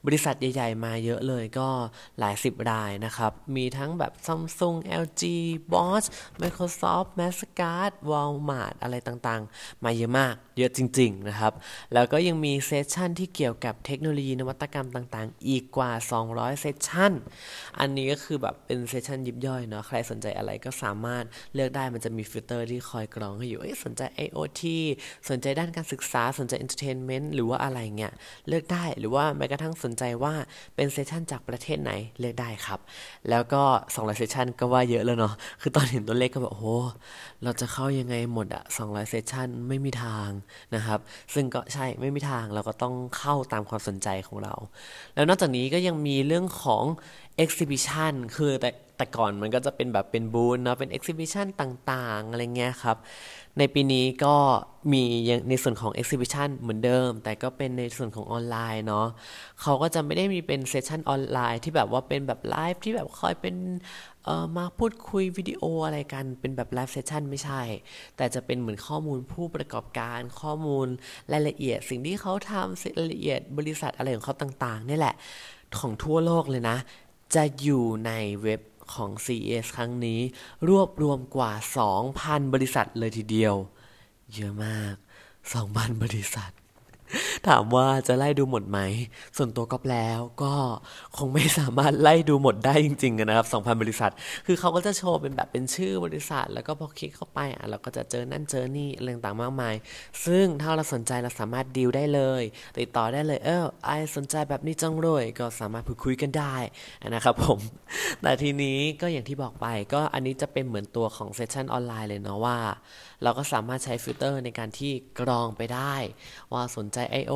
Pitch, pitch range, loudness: 130 Hz, 115-145 Hz, -28 LUFS